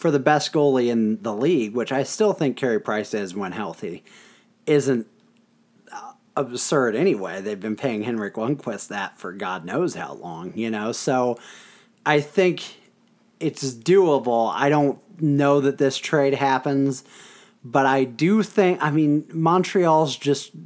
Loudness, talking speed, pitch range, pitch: -22 LUFS, 150 wpm, 130-165 Hz, 145 Hz